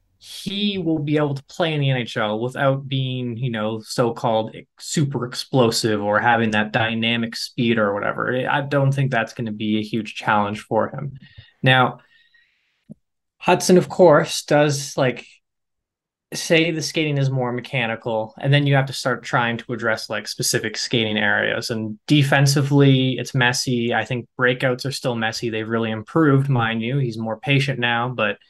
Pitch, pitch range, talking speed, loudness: 125 Hz, 115-140 Hz, 170 wpm, -20 LUFS